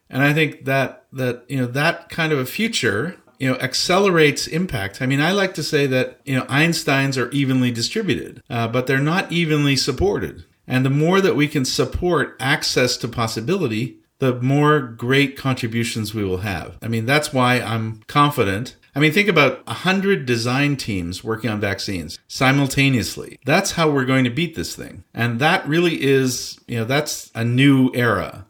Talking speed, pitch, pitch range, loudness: 185 wpm, 130 Hz, 120-150 Hz, -19 LUFS